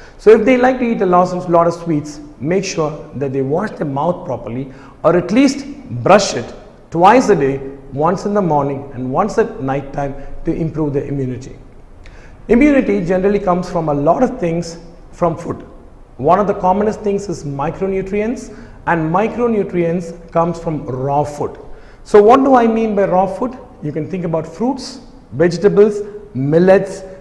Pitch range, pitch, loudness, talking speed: 150-210 Hz, 175 Hz, -15 LUFS, 170 wpm